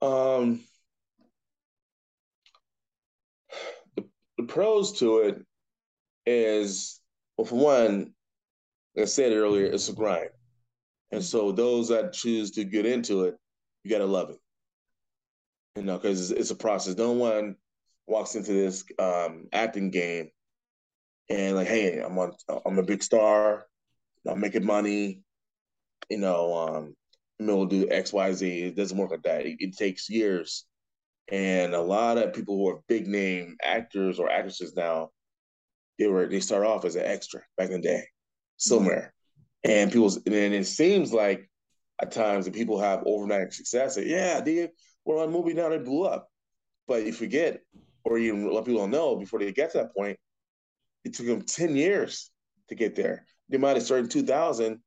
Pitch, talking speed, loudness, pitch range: 105 Hz, 165 wpm, -27 LUFS, 95-120 Hz